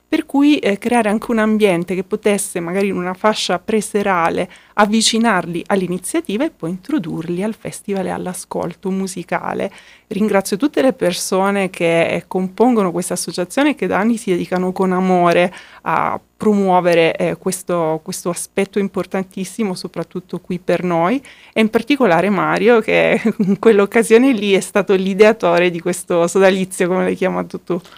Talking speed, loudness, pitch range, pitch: 150 wpm, -17 LUFS, 180-215 Hz, 190 Hz